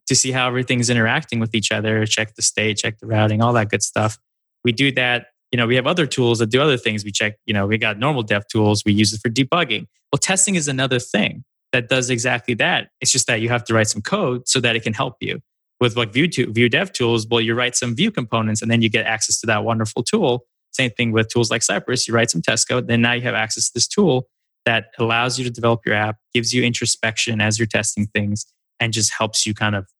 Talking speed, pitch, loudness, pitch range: 260 wpm, 115 Hz, -18 LUFS, 110-125 Hz